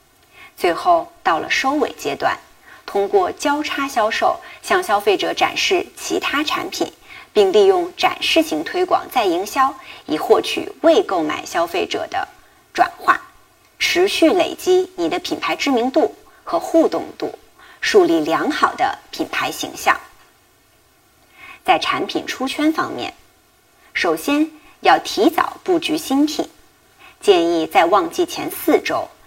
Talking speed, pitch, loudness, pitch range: 195 characters per minute, 365 Hz, -18 LUFS, 345-370 Hz